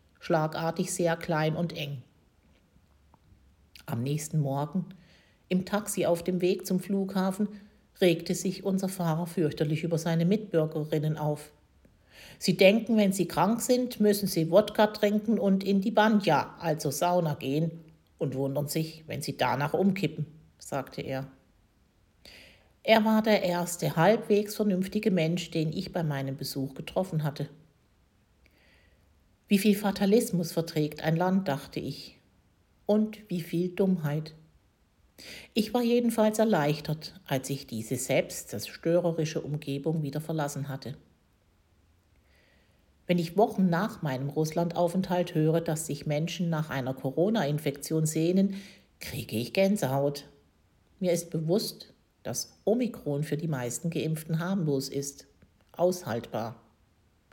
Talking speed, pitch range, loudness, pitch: 125 wpm, 140-185 Hz, -29 LUFS, 160 Hz